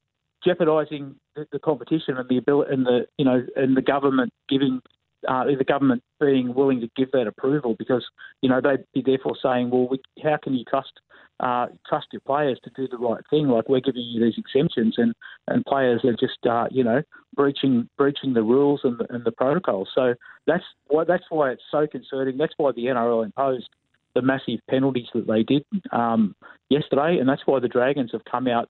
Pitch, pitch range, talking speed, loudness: 130 Hz, 120-140 Hz, 205 wpm, -23 LUFS